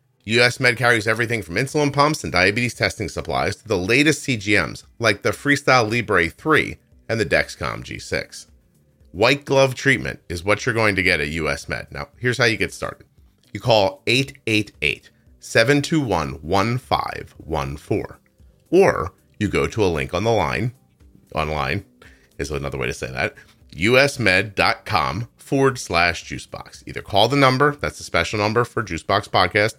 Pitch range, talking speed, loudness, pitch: 85-130 Hz, 155 wpm, -20 LUFS, 115 Hz